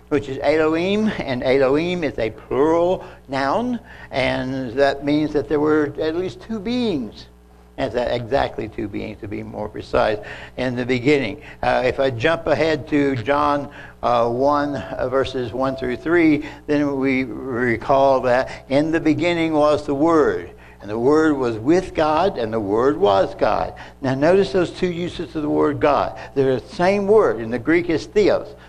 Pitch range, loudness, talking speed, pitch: 130-160 Hz, -20 LUFS, 175 wpm, 140 Hz